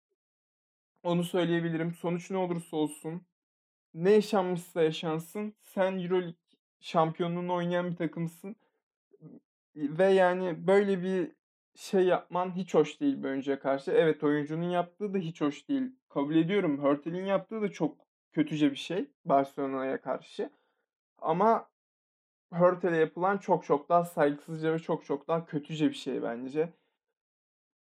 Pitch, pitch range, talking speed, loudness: 175 Hz, 155-190 Hz, 125 wpm, -30 LUFS